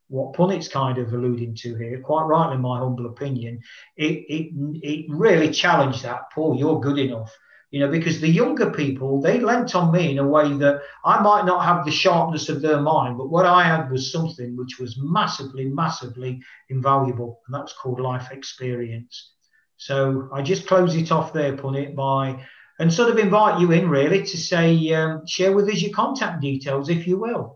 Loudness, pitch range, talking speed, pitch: -21 LUFS, 135-170 Hz, 195 wpm, 150 Hz